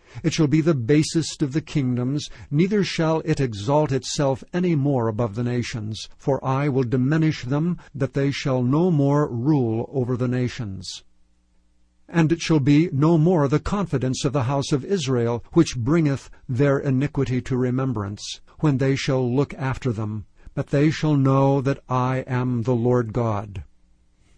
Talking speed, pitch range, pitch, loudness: 165 wpm, 120-150 Hz, 135 Hz, -22 LUFS